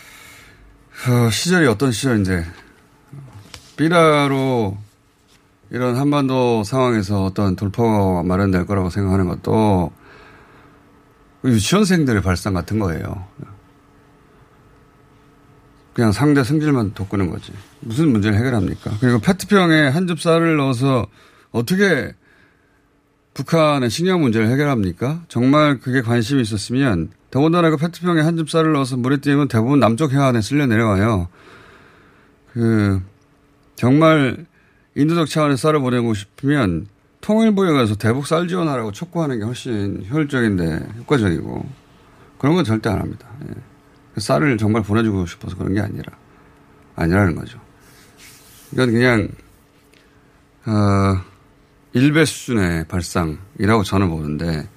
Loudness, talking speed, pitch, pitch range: -18 LUFS, 275 characters per minute, 120 Hz, 100-145 Hz